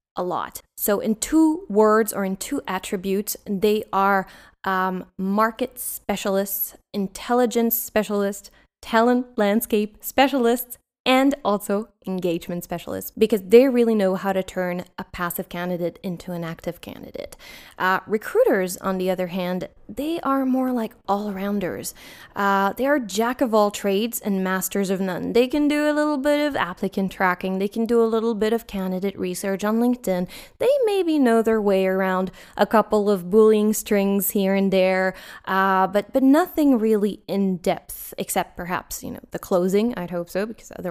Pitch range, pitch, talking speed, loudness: 190-230 Hz, 205 Hz, 165 wpm, -22 LUFS